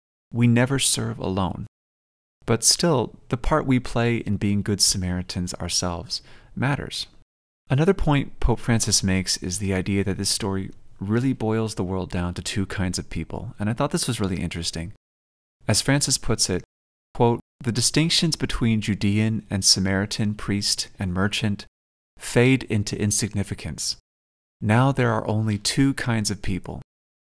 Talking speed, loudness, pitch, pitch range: 150 wpm, -23 LUFS, 105 Hz, 90-115 Hz